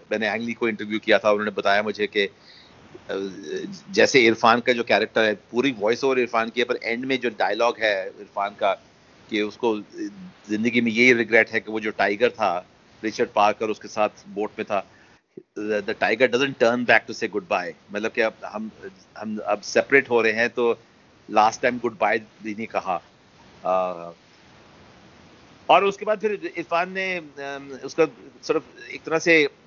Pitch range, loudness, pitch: 105-135 Hz, -22 LUFS, 115 Hz